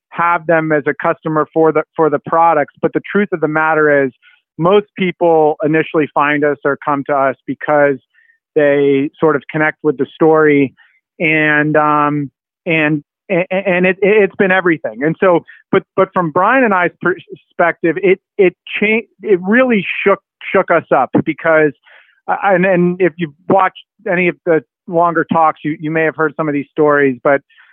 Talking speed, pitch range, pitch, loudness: 175 wpm, 150-185 Hz, 160 Hz, -14 LUFS